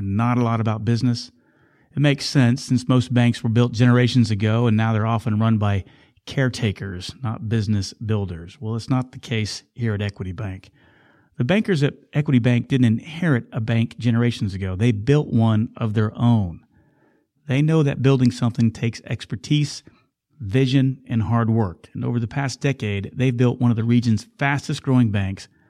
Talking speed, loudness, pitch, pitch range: 175 wpm, -21 LUFS, 120 Hz, 110-130 Hz